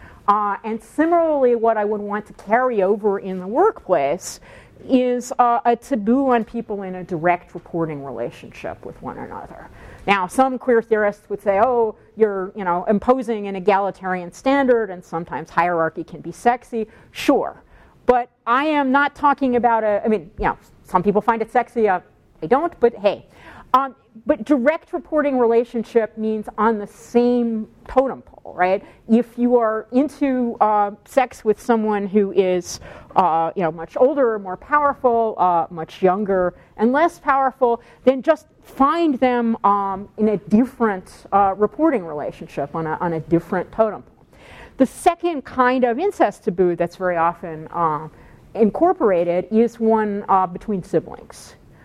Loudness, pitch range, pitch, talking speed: -20 LUFS, 190-250 Hz, 220 Hz, 160 wpm